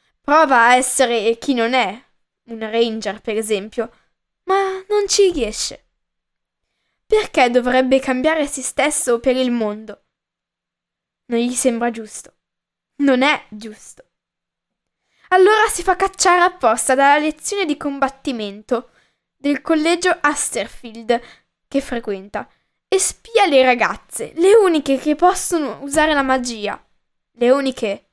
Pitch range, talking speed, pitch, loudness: 235-315 Hz, 120 wpm, 265 Hz, -17 LUFS